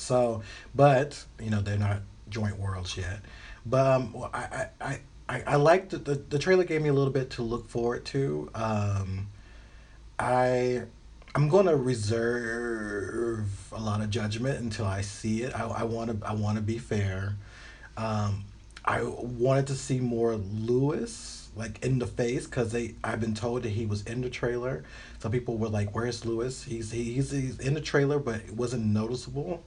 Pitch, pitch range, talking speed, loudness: 115 Hz, 110-125 Hz, 175 wpm, -29 LUFS